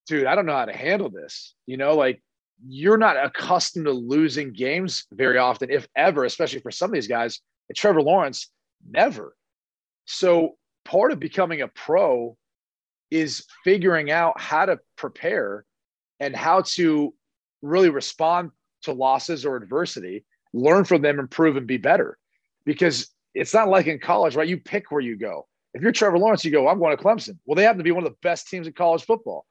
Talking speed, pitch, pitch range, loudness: 195 wpm, 165 Hz, 140-185 Hz, -22 LUFS